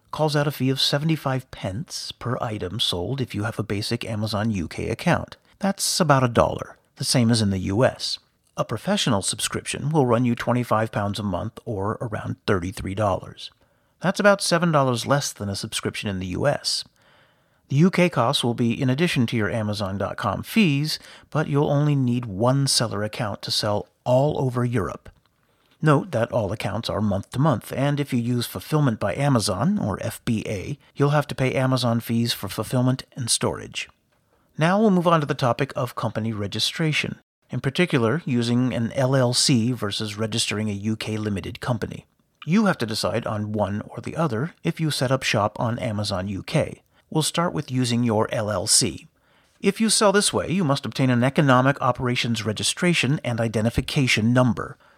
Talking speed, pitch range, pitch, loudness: 175 wpm, 110-145 Hz, 125 Hz, -23 LUFS